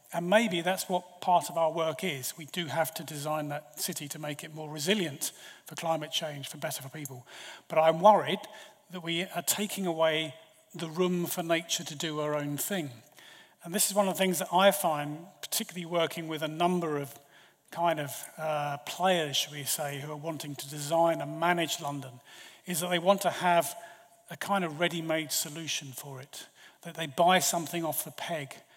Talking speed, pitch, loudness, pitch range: 200 wpm, 165 Hz, -30 LUFS, 150-180 Hz